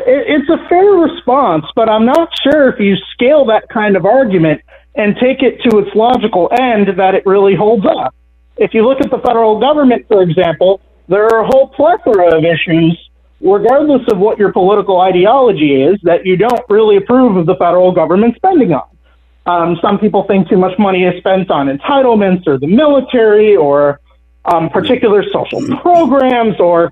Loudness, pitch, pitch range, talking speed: -10 LUFS, 210 Hz, 180-255 Hz, 180 wpm